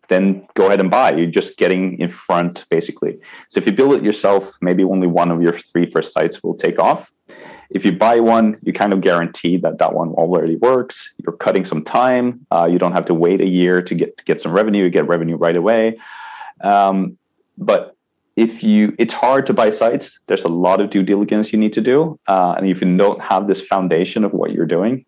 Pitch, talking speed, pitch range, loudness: 95 Hz, 225 wpm, 90-110 Hz, -16 LUFS